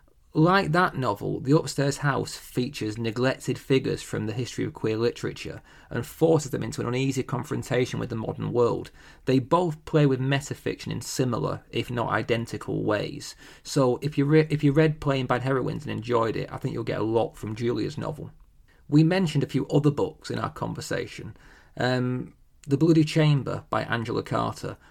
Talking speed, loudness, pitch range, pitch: 180 wpm, -26 LUFS, 120-150 Hz, 135 Hz